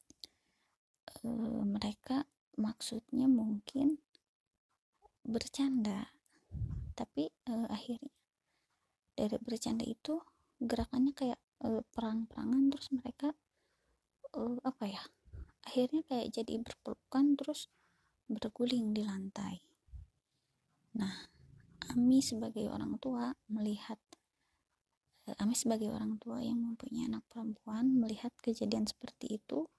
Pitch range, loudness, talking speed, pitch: 220-265 Hz, -37 LUFS, 95 wpm, 235 Hz